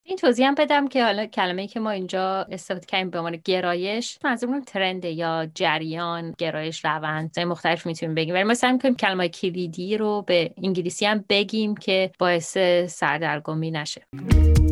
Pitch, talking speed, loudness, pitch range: 185 Hz, 165 wpm, -23 LUFS, 170-210 Hz